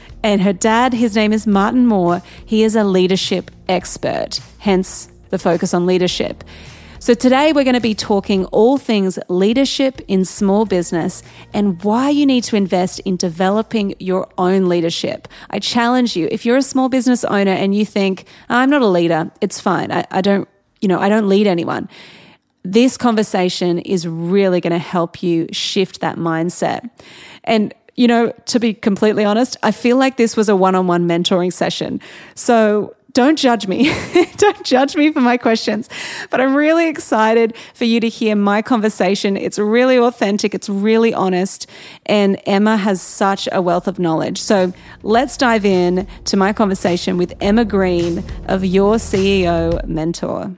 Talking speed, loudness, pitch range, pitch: 170 wpm, -16 LUFS, 185-235 Hz, 205 Hz